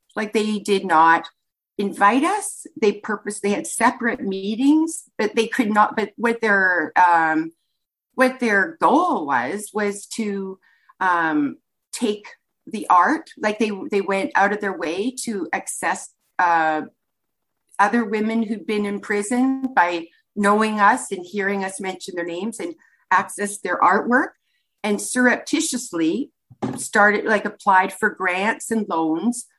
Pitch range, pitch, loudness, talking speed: 195-240 Hz, 210 Hz, -20 LUFS, 140 wpm